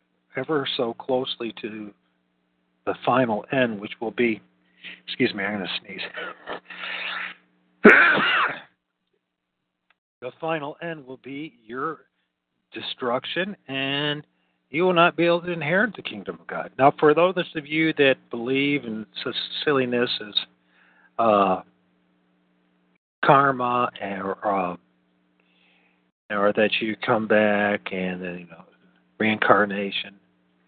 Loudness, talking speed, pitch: -23 LUFS, 115 wpm, 105 Hz